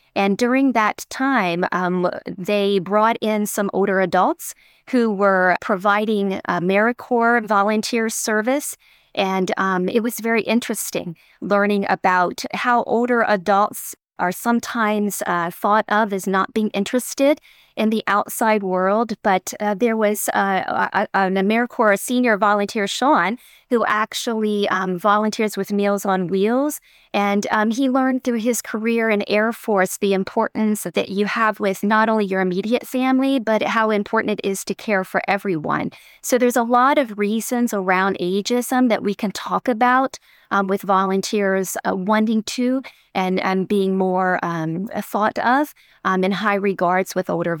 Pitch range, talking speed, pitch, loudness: 195-230 Hz, 155 wpm, 210 Hz, -19 LUFS